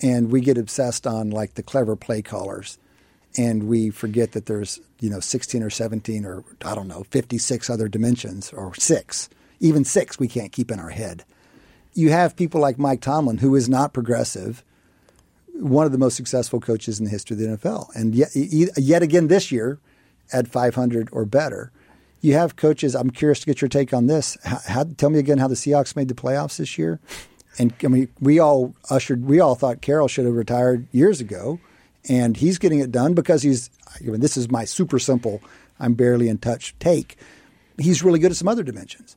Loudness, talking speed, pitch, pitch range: -21 LUFS, 210 wpm, 125 Hz, 115-145 Hz